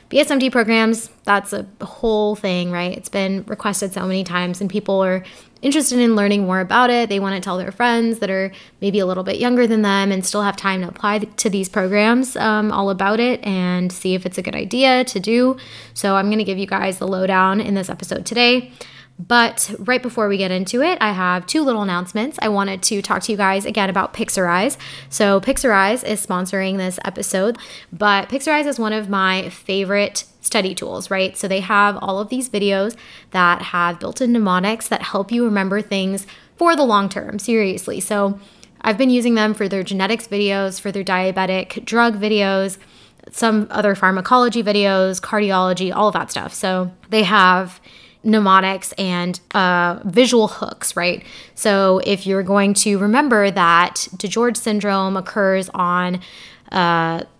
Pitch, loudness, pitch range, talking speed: 200 Hz, -18 LUFS, 190-220 Hz, 185 wpm